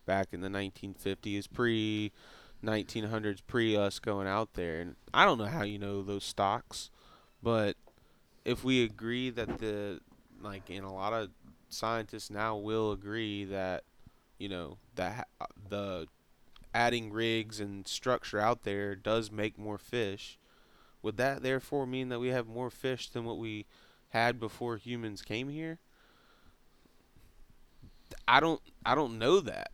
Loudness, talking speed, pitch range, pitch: -34 LUFS, 150 wpm, 100-115 Hz, 110 Hz